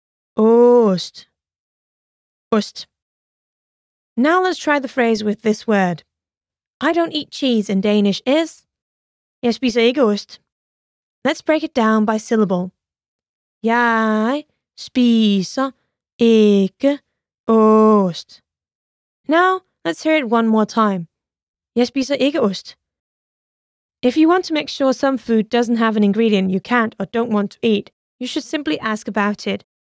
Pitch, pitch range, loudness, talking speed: 230 Hz, 210-270 Hz, -17 LUFS, 125 wpm